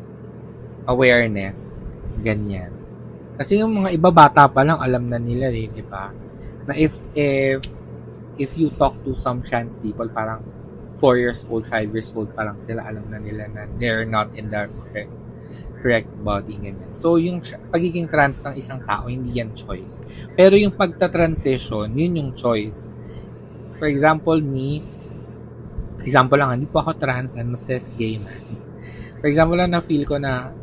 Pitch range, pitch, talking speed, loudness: 110-145 Hz, 120 Hz, 165 wpm, -20 LUFS